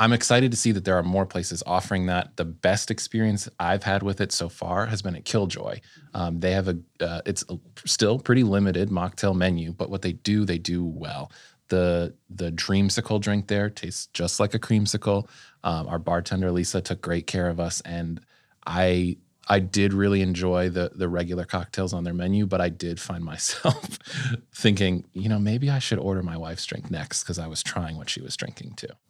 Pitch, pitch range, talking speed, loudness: 95 Hz, 85-105 Hz, 205 wpm, -25 LUFS